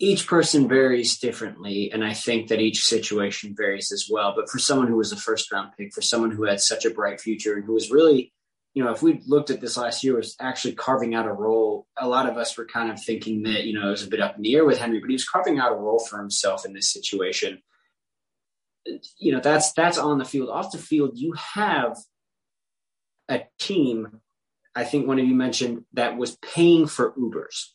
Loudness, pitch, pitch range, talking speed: -23 LUFS, 115 Hz, 110-135 Hz, 230 wpm